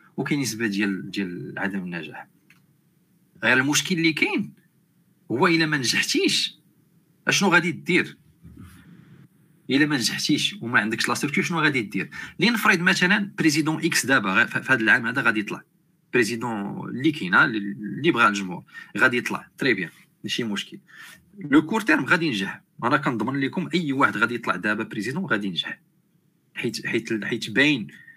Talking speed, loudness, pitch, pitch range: 145 wpm, -22 LUFS, 150 Hz, 115-175 Hz